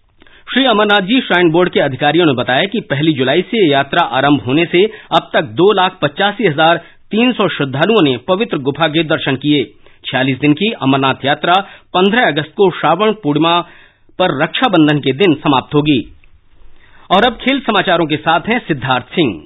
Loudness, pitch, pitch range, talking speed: -13 LUFS, 170 Hz, 145-200 Hz, 175 wpm